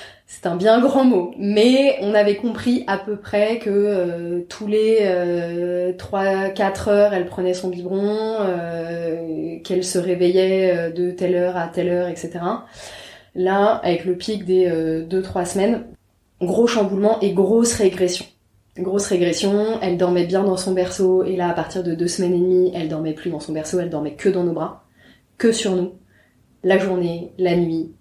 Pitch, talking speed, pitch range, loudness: 185 Hz, 180 wpm, 175-200 Hz, -20 LUFS